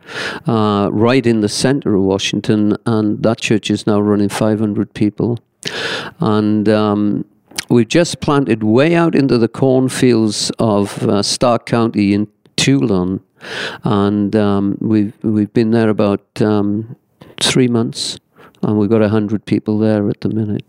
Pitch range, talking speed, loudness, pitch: 105-115 Hz, 145 wpm, -15 LUFS, 110 Hz